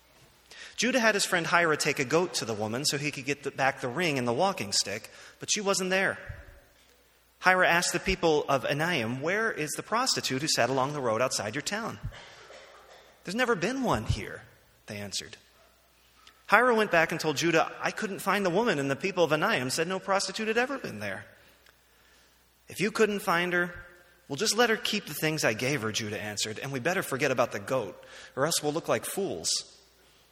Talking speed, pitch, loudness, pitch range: 210 wpm, 170 Hz, -28 LUFS, 140-195 Hz